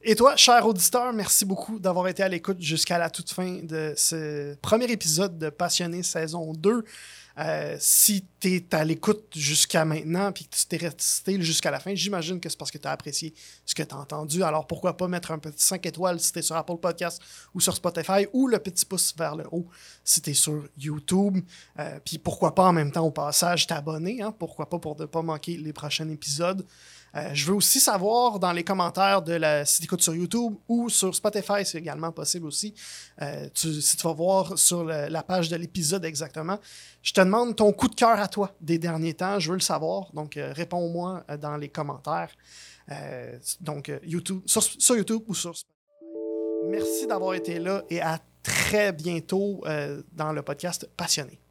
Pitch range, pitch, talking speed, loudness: 160-195 Hz, 175 Hz, 210 wpm, -25 LUFS